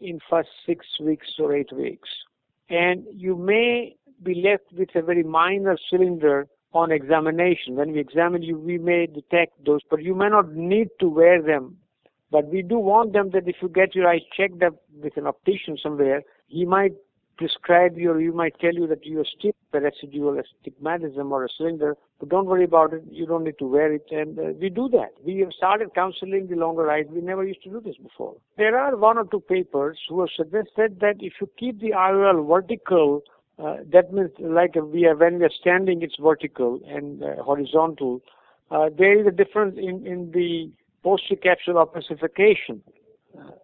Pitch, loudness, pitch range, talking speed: 170 Hz, -22 LUFS, 155-190 Hz, 200 wpm